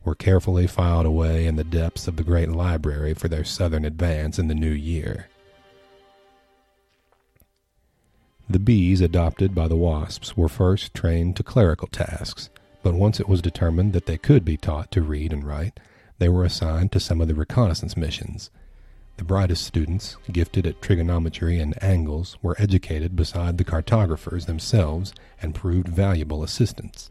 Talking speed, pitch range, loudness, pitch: 160 wpm, 80-95 Hz, -23 LUFS, 85 Hz